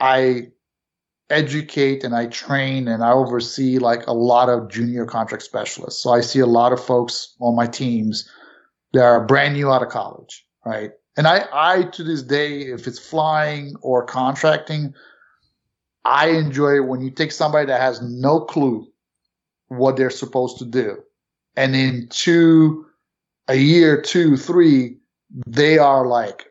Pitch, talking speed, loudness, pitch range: 130 Hz, 160 wpm, -18 LUFS, 120-150 Hz